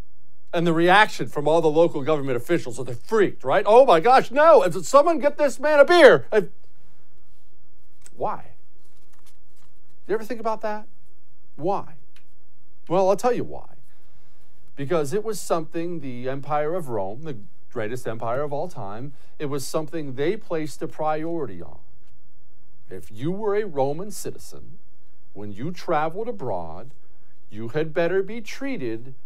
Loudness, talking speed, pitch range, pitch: -22 LUFS, 155 wpm, 130-195 Hz, 155 Hz